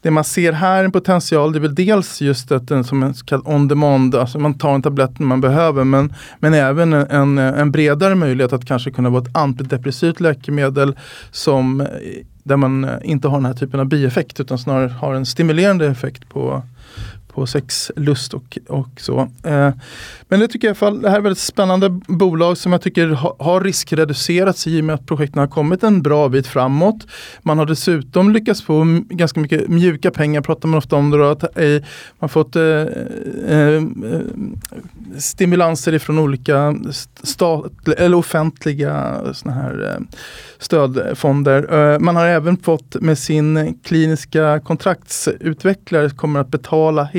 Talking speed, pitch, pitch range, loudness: 175 wpm, 150 Hz, 140-170 Hz, -16 LUFS